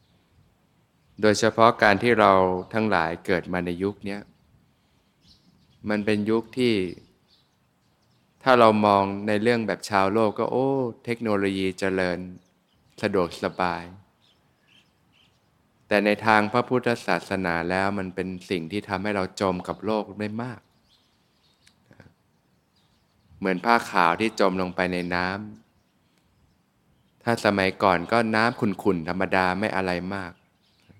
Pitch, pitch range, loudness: 100 Hz, 95-110 Hz, -24 LUFS